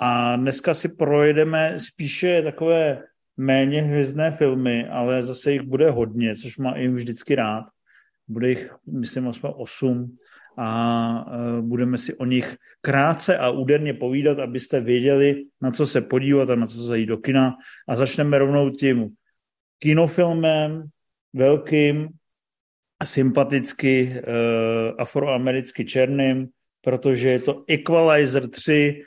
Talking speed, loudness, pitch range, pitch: 125 wpm, -21 LUFS, 125-150 Hz, 135 Hz